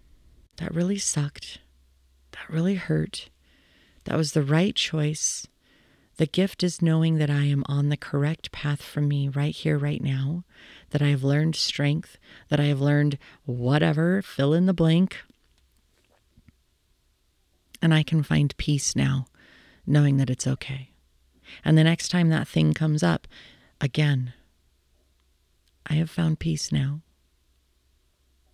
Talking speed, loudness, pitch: 140 wpm, -24 LUFS, 145 Hz